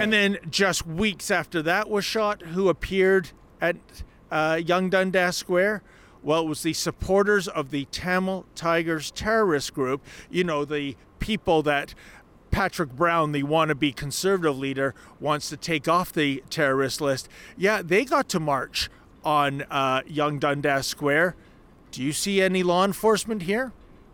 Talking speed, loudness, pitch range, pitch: 150 wpm, -24 LUFS, 145-190 Hz, 165 Hz